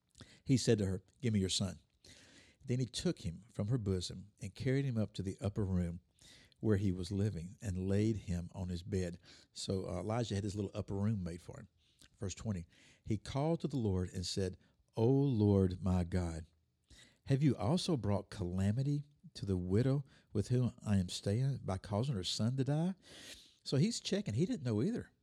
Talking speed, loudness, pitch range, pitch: 195 wpm, -37 LUFS, 95-125 Hz, 100 Hz